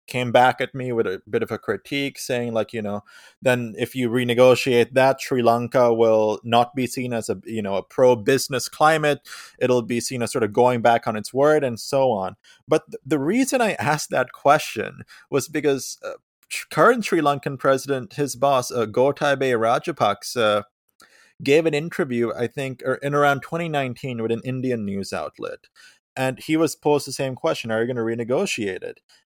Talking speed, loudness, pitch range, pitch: 190 wpm, -21 LUFS, 120-145 Hz, 130 Hz